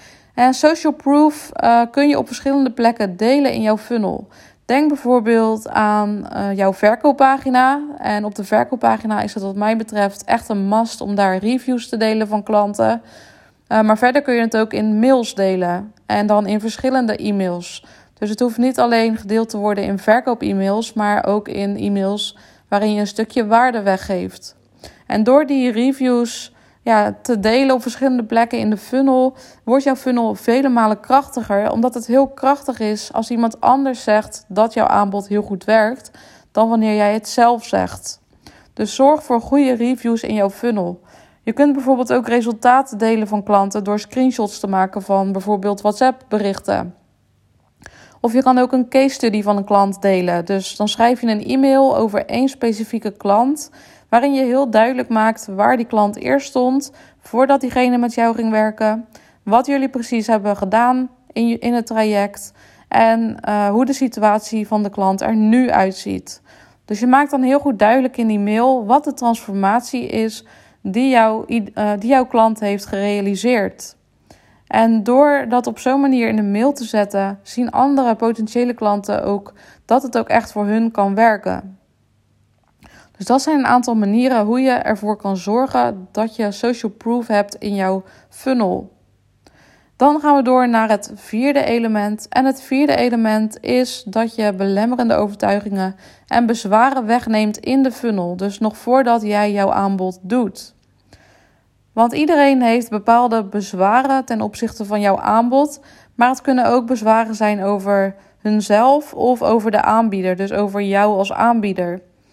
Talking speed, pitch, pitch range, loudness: 170 wpm, 225 Hz, 205-250 Hz, -17 LUFS